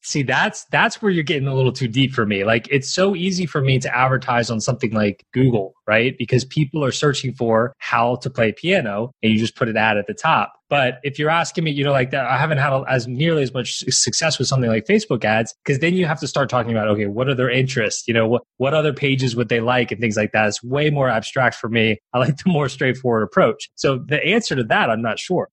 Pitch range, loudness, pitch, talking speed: 115-145 Hz, -19 LUFS, 130 Hz, 260 wpm